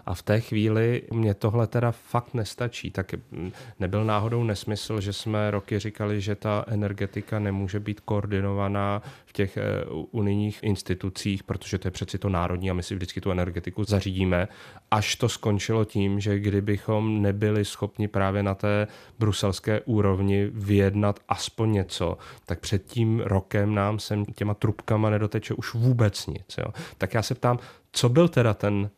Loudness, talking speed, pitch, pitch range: -26 LUFS, 160 wpm, 105 Hz, 100-110 Hz